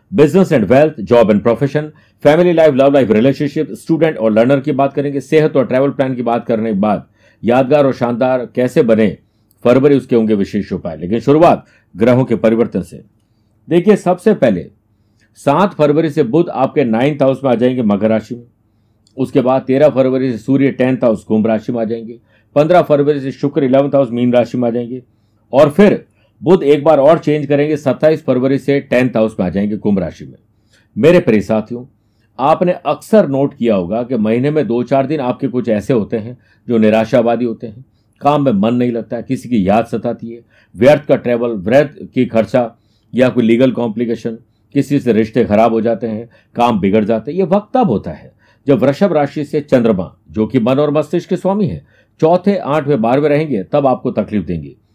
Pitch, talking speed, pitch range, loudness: 125 Hz, 200 wpm, 110-145 Hz, -13 LUFS